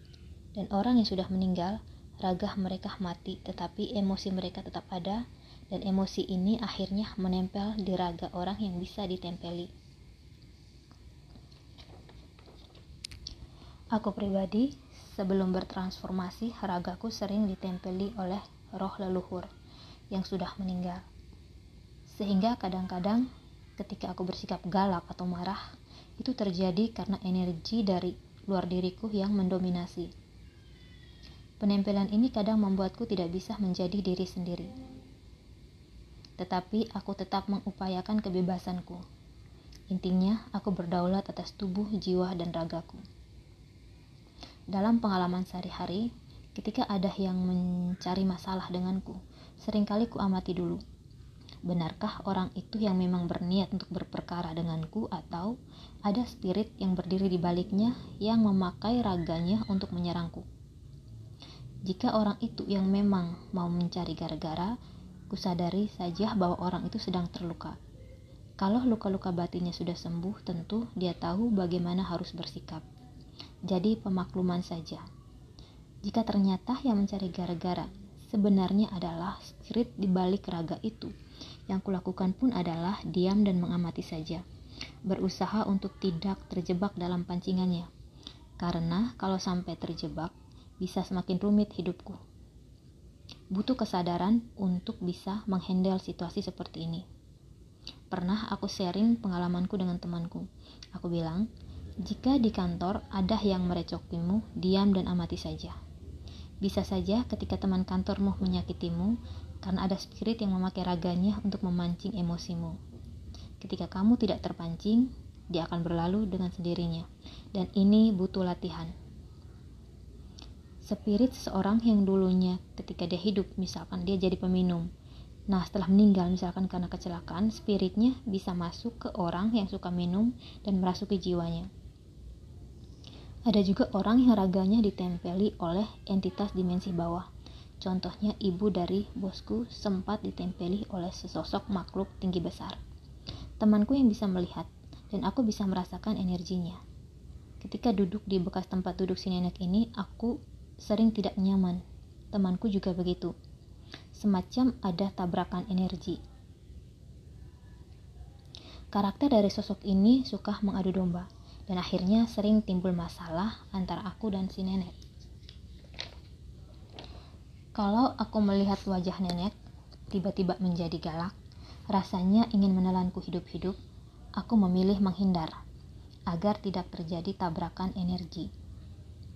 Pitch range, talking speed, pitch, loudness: 175-200 Hz, 115 wpm, 185 Hz, -31 LUFS